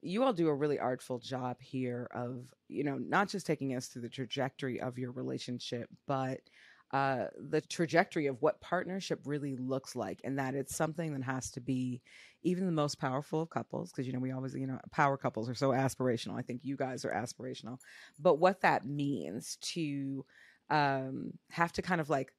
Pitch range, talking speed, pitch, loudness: 130-155 Hz, 200 wpm, 135 Hz, -35 LUFS